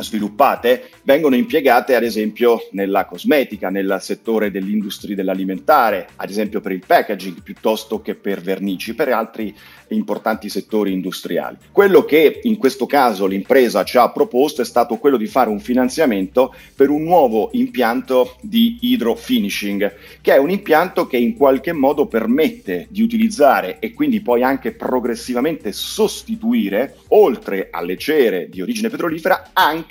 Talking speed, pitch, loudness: 140 wpm, 125 Hz, -17 LUFS